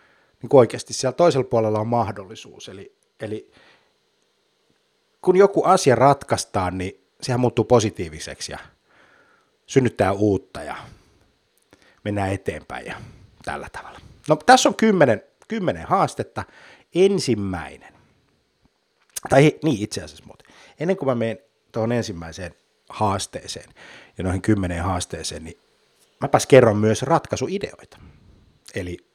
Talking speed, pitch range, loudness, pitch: 110 wpm, 100-155 Hz, -20 LUFS, 115 Hz